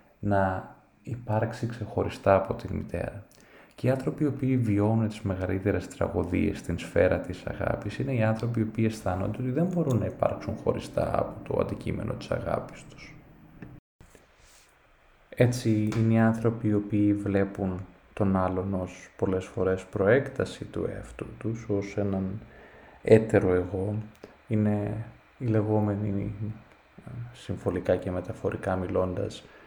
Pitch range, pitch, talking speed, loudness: 95-110 Hz, 105 Hz, 130 wpm, -28 LUFS